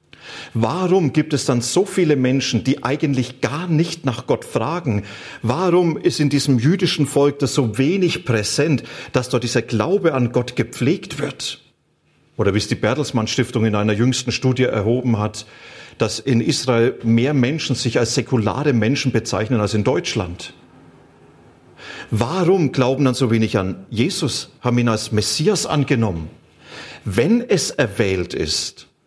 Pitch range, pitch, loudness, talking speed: 115-145 Hz, 130 Hz, -19 LUFS, 150 wpm